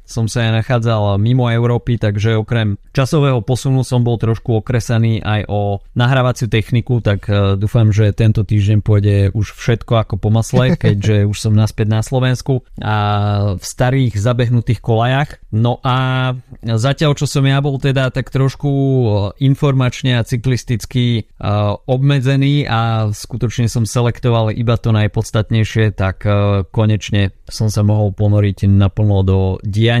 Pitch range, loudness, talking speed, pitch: 105-125 Hz, -15 LUFS, 140 wpm, 115 Hz